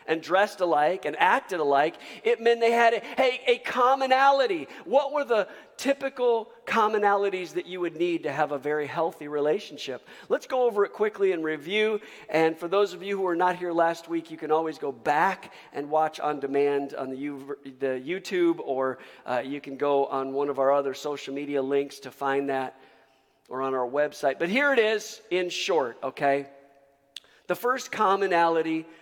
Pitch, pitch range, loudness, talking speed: 165 Hz, 140-210 Hz, -26 LUFS, 190 wpm